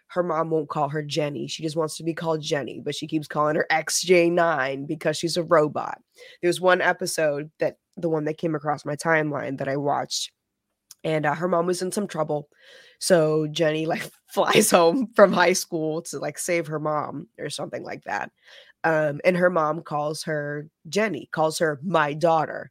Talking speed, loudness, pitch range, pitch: 195 wpm, -24 LUFS, 150-175 Hz, 160 Hz